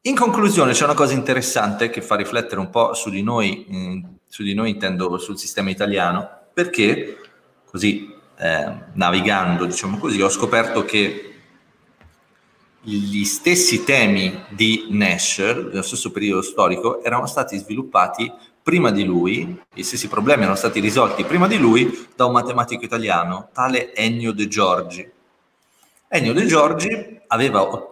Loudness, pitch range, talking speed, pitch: -19 LUFS, 100-135 Hz, 145 wpm, 115 Hz